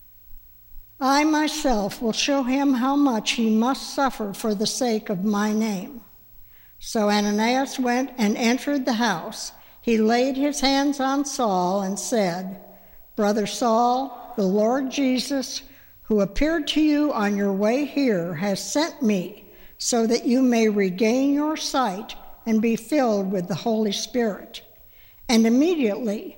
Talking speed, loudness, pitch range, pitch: 145 wpm, -22 LUFS, 205-265 Hz, 230 Hz